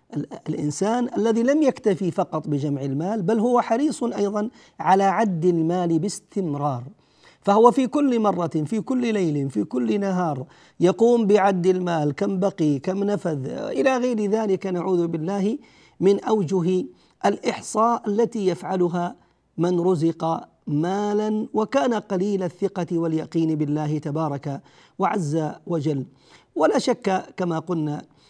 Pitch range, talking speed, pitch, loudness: 160-215 Hz, 120 wpm, 190 Hz, -23 LUFS